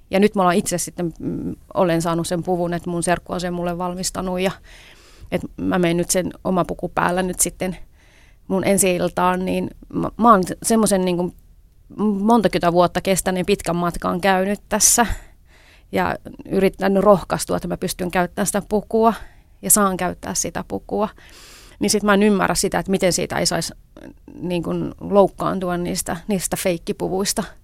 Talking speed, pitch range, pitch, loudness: 160 wpm, 175-195 Hz, 185 Hz, -20 LUFS